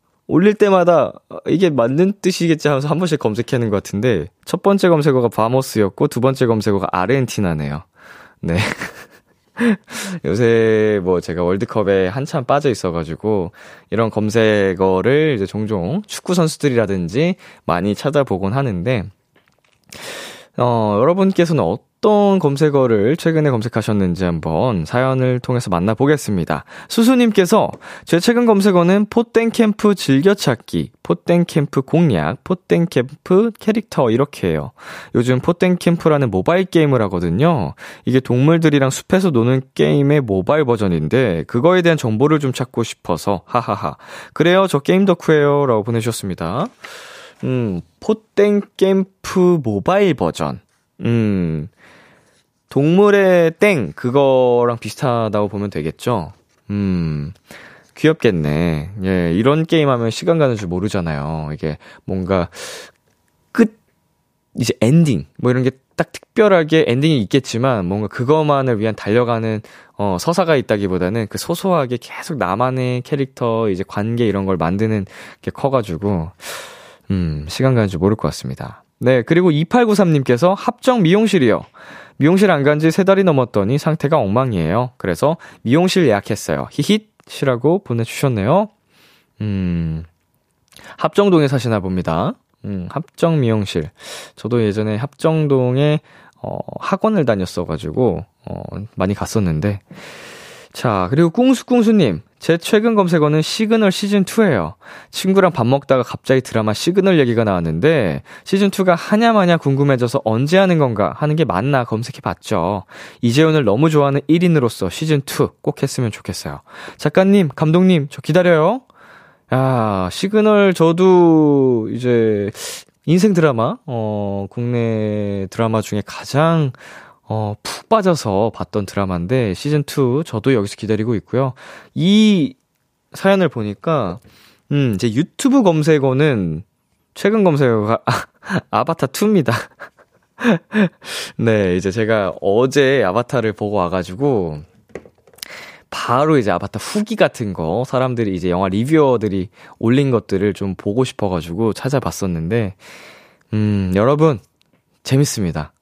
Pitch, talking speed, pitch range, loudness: 130 Hz, 290 characters per minute, 105-165 Hz, -16 LUFS